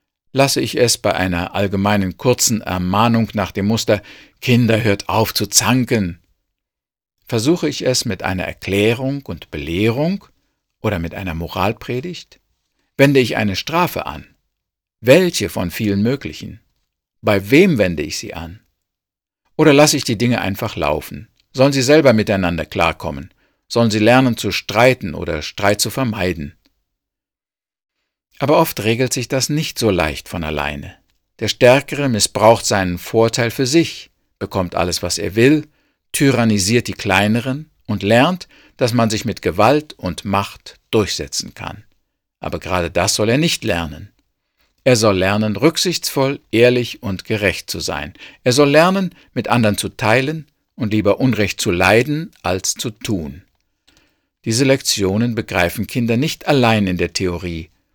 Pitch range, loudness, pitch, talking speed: 95-130 Hz, -17 LUFS, 110 Hz, 145 wpm